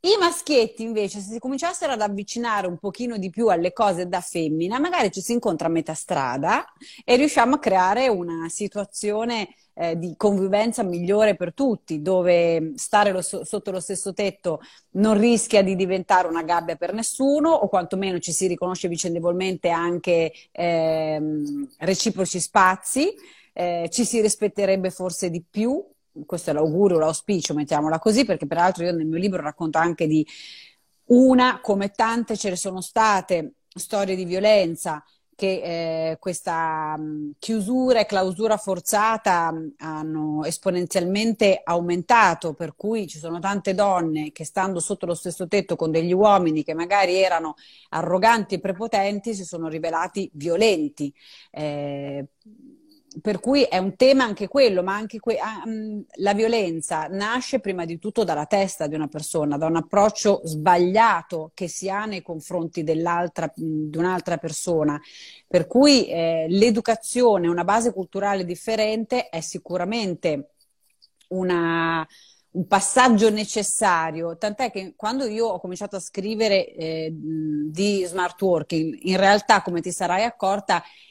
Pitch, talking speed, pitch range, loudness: 185 Hz, 145 wpm, 165-215 Hz, -22 LUFS